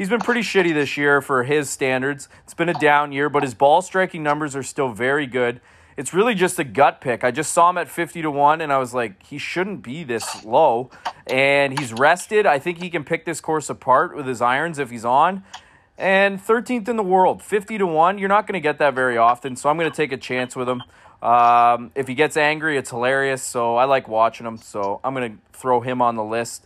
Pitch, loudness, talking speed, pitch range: 140 Hz, -20 LUFS, 245 wpm, 125-170 Hz